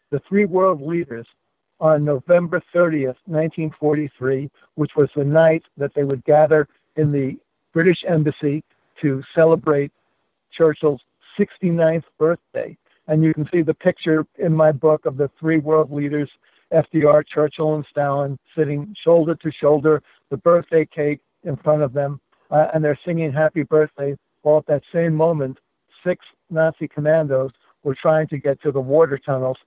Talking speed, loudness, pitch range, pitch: 155 wpm, -19 LUFS, 145-160 Hz, 155 Hz